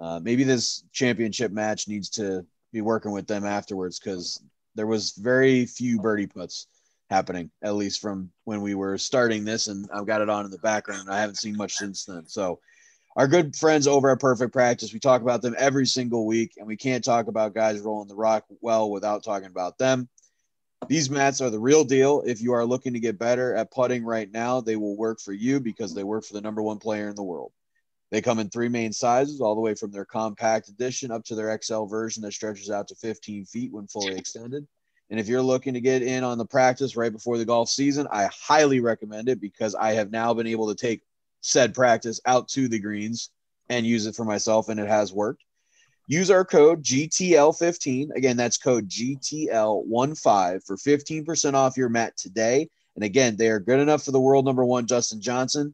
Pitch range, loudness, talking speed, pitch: 105-130 Hz, -24 LUFS, 215 wpm, 115 Hz